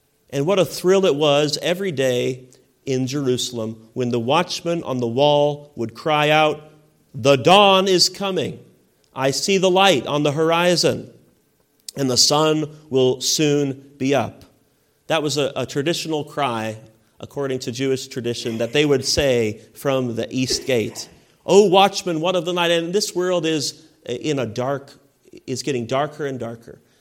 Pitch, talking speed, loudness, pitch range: 140 Hz, 160 wpm, -19 LUFS, 130-160 Hz